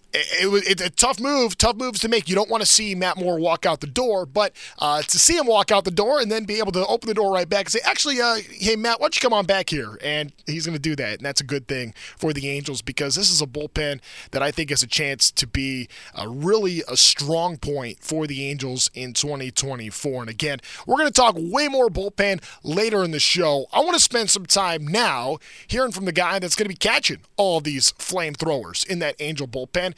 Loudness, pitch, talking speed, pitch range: -20 LUFS, 175 Hz, 250 wpm, 145-210 Hz